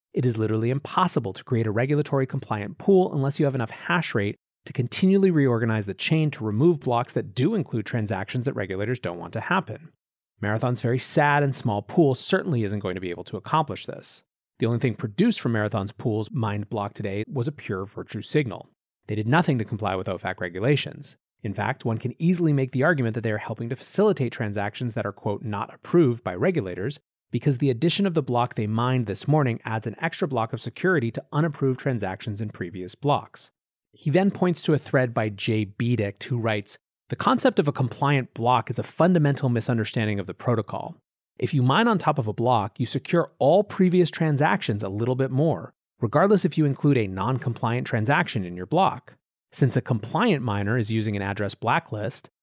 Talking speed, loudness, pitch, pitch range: 205 wpm, -25 LUFS, 125 Hz, 110-145 Hz